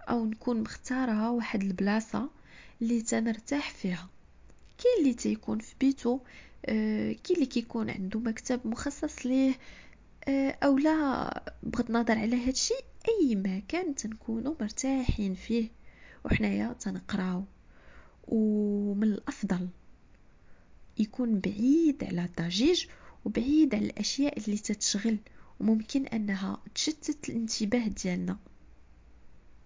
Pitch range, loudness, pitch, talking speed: 210-265 Hz, -30 LUFS, 230 Hz, 105 wpm